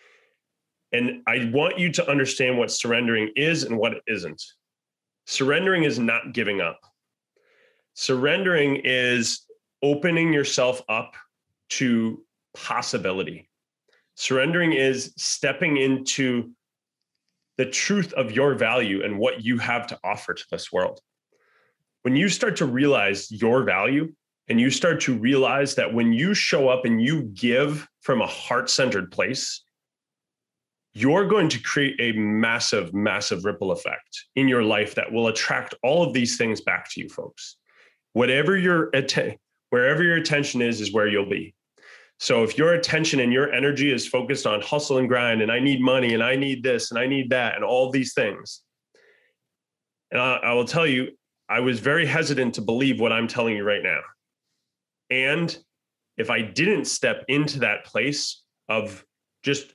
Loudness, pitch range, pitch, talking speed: -22 LUFS, 120-165 Hz, 135 Hz, 160 wpm